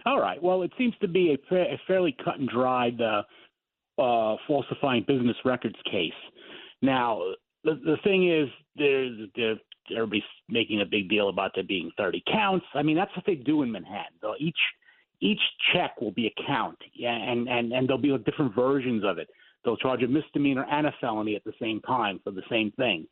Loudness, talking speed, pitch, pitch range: -27 LUFS, 190 wpm, 135 Hz, 115-155 Hz